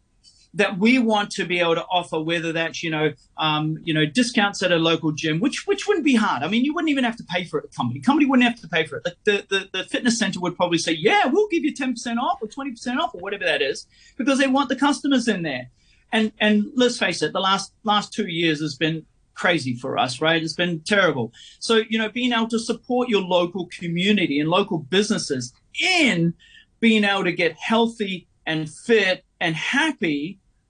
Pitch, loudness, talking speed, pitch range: 200 Hz, -21 LUFS, 230 wpm, 165-245 Hz